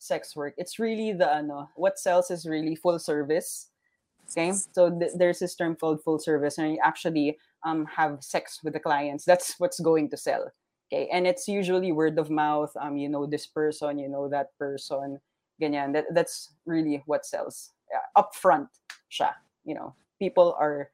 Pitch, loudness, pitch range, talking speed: 160 Hz, -27 LUFS, 150-180 Hz, 185 wpm